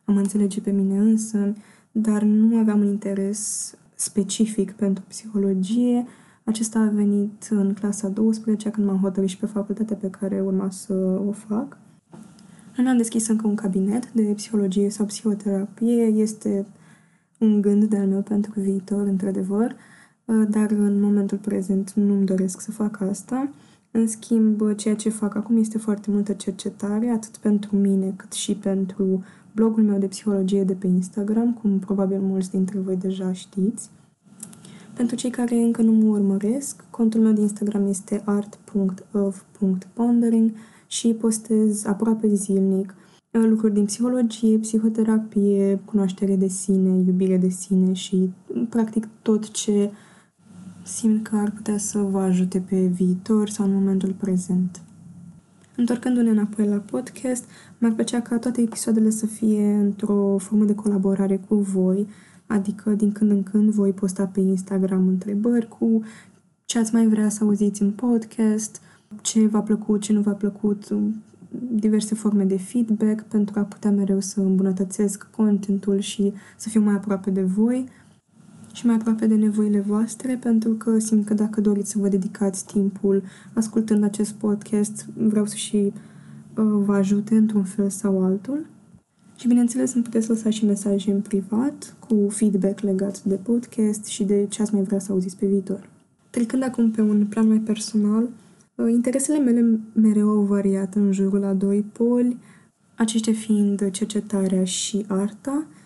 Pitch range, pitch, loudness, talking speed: 195-220 Hz, 205 Hz, -22 LUFS, 150 wpm